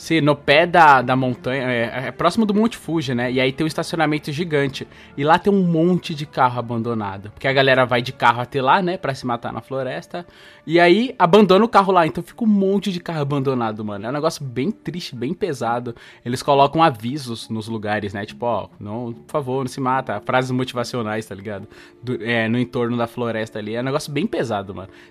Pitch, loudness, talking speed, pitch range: 130 Hz, -19 LUFS, 220 wpm, 120-165 Hz